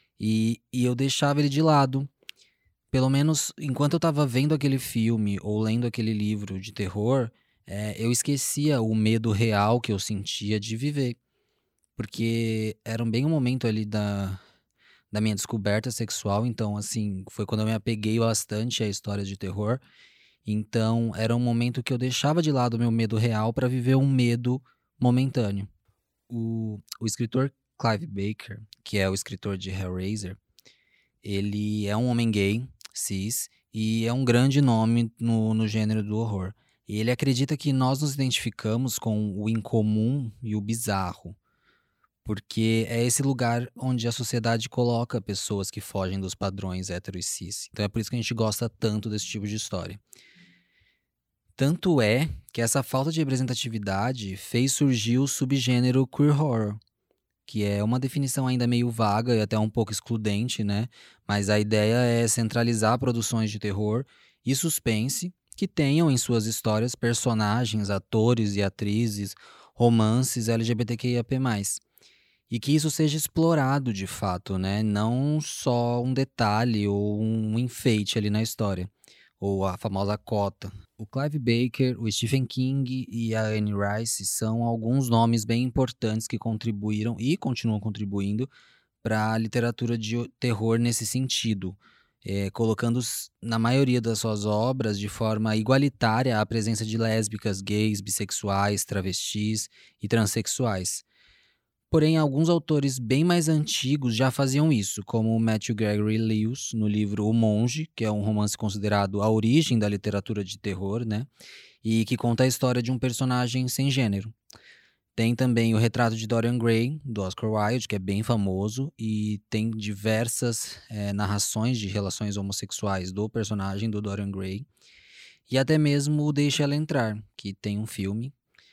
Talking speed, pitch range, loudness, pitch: 155 wpm, 105-125 Hz, -26 LUFS, 115 Hz